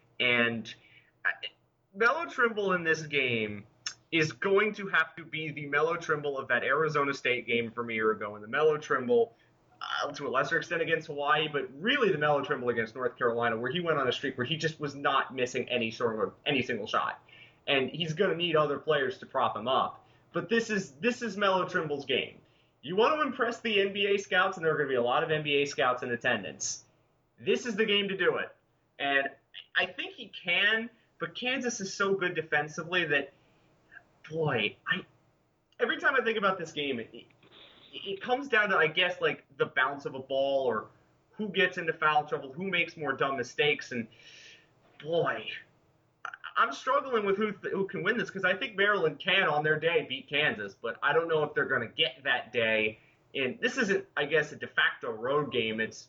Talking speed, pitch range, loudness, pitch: 205 wpm, 135-200 Hz, -29 LUFS, 160 Hz